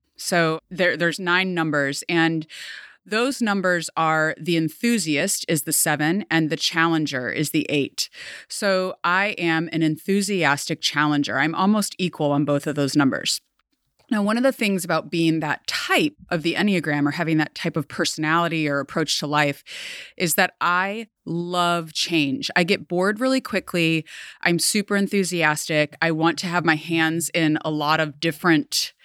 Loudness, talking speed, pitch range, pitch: -21 LUFS, 165 wpm, 155-185 Hz, 165 Hz